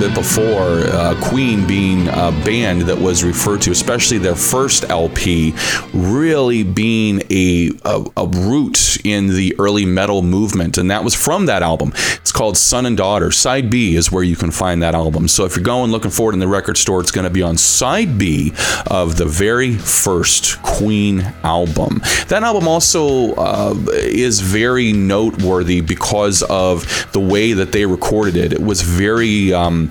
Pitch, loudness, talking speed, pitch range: 95 Hz, -14 LUFS, 175 wpm, 90-105 Hz